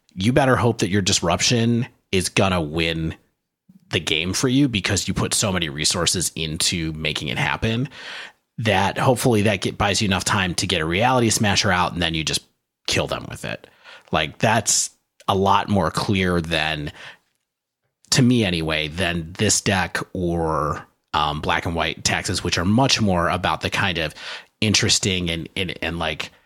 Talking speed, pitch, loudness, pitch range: 175 wpm, 95 Hz, -20 LUFS, 85-110 Hz